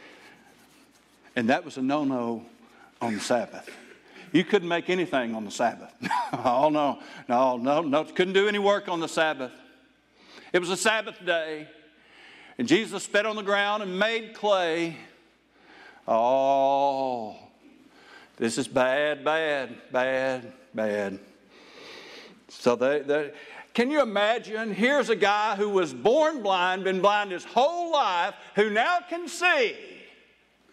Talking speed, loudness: 135 wpm, -25 LUFS